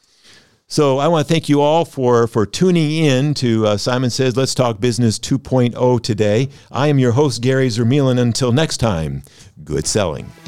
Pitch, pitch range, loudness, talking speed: 130 Hz, 120-145 Hz, -16 LUFS, 180 wpm